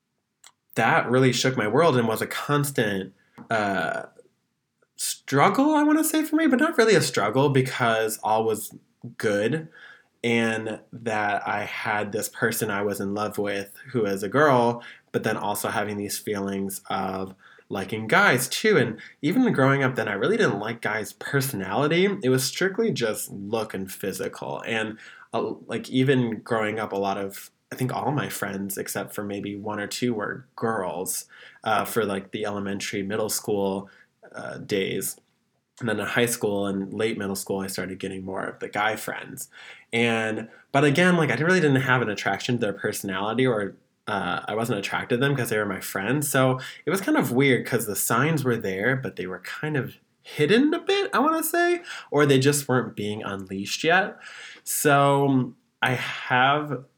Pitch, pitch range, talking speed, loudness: 115 Hz, 100-140 Hz, 185 wpm, -24 LUFS